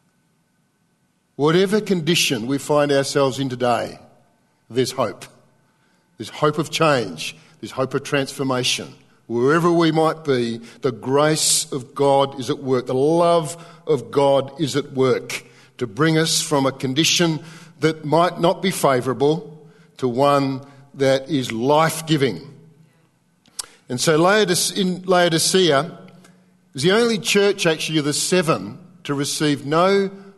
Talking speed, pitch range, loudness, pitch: 130 wpm, 140-170 Hz, -19 LUFS, 150 Hz